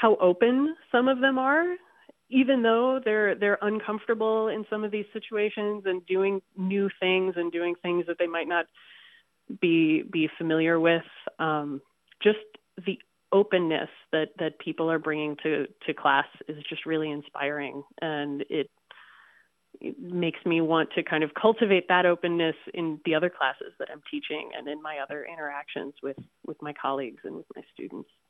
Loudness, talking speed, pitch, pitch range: -27 LUFS, 170 wpm, 175 Hz, 155-215 Hz